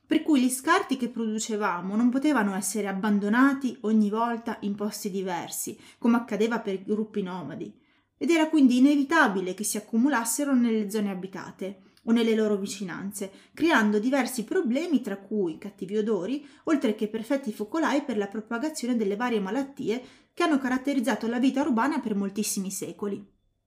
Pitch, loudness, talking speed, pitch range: 225 Hz, -26 LUFS, 155 wpm, 205-270 Hz